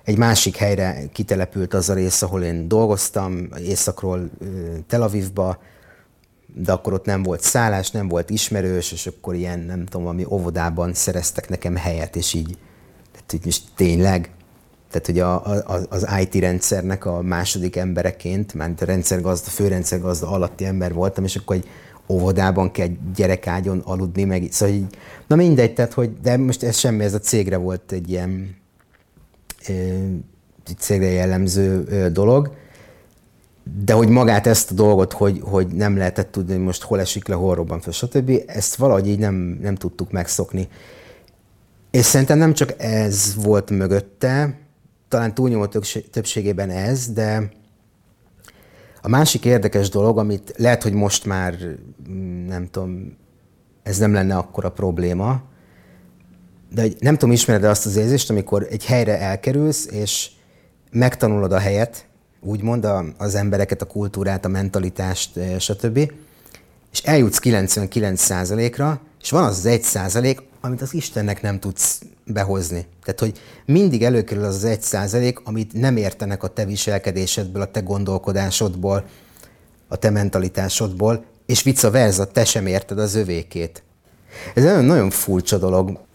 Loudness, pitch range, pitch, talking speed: -19 LUFS, 90-110 Hz, 100 Hz, 145 wpm